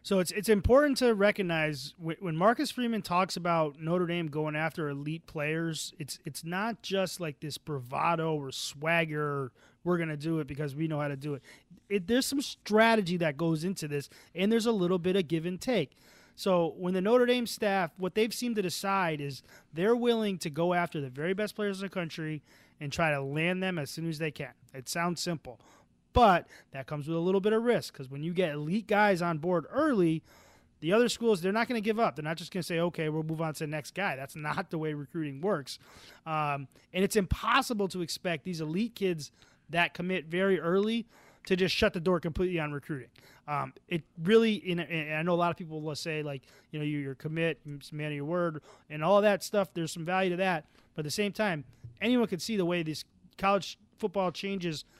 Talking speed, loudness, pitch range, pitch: 225 wpm, -30 LUFS, 155-195 Hz, 170 Hz